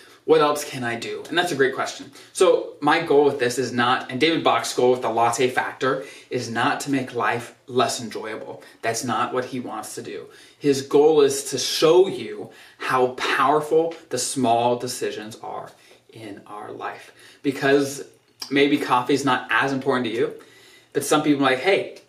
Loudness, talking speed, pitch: -21 LUFS, 185 wpm, 145 Hz